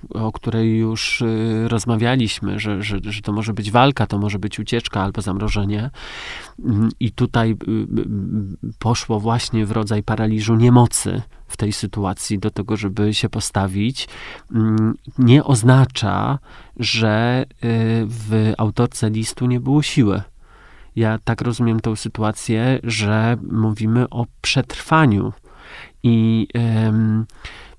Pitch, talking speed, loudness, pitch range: 110 Hz, 110 wpm, -19 LUFS, 105-120 Hz